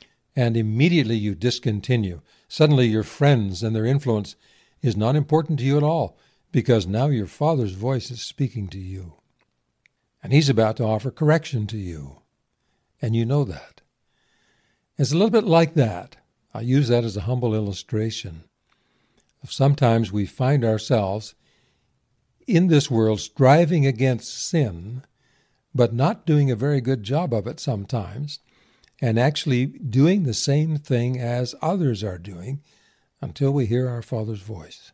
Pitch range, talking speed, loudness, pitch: 110-140 Hz, 150 wpm, -22 LUFS, 125 Hz